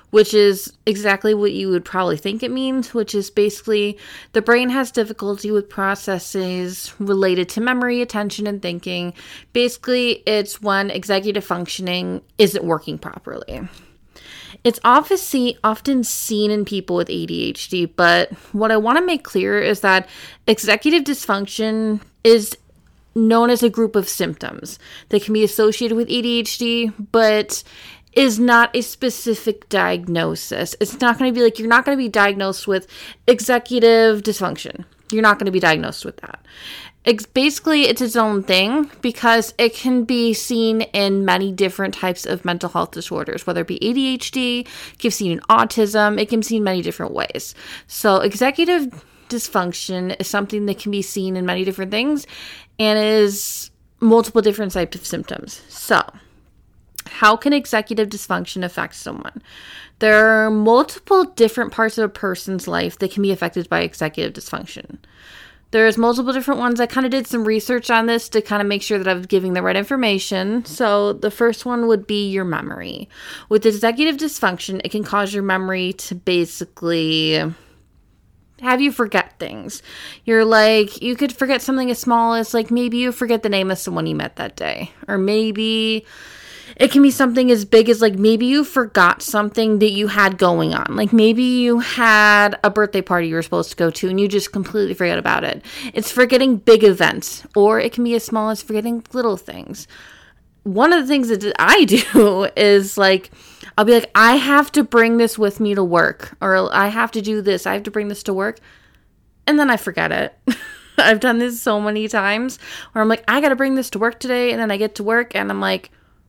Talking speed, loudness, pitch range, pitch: 185 wpm, -17 LUFS, 195-240 Hz, 215 Hz